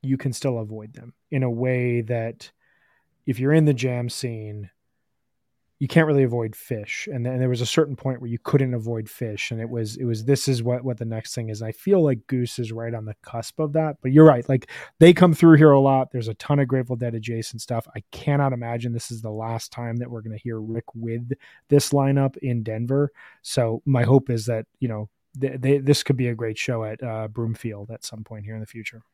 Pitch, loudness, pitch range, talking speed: 120 Hz, -22 LUFS, 115-135 Hz, 250 wpm